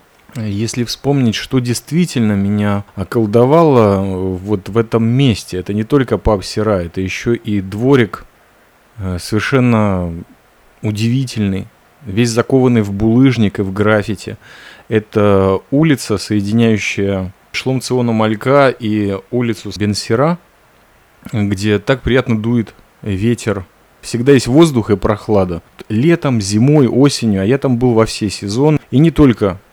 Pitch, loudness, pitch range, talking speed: 110 Hz, -14 LUFS, 100-125 Hz, 120 wpm